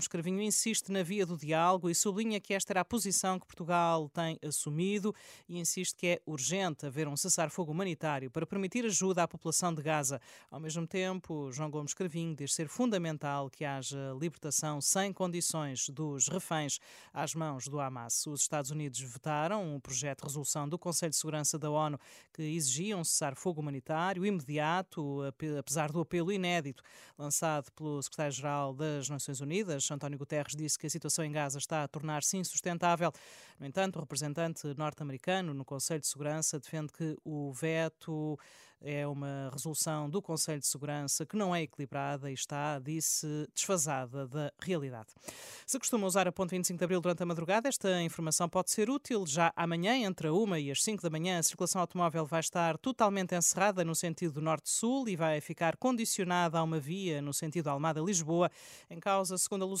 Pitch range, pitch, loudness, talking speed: 150-180 Hz, 160 Hz, -34 LUFS, 180 wpm